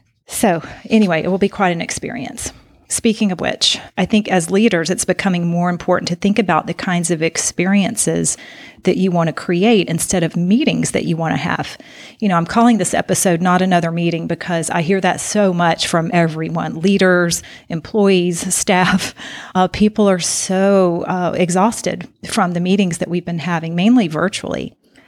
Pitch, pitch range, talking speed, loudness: 180 Hz, 170-195 Hz, 175 wpm, -16 LUFS